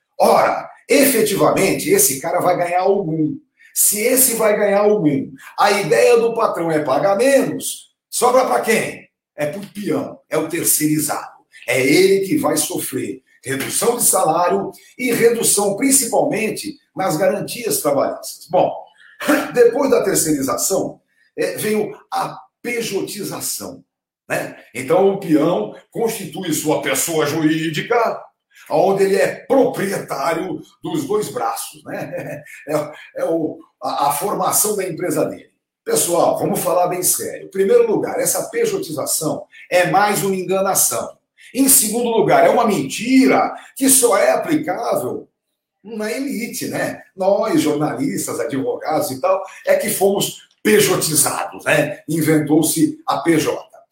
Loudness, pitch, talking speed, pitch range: -17 LUFS, 210 Hz, 130 wpm, 180-285 Hz